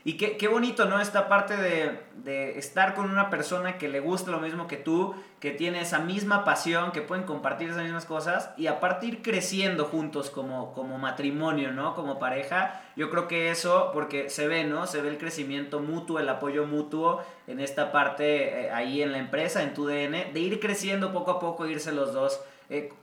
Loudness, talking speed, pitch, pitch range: -28 LUFS, 205 wpm, 160 Hz, 145-185 Hz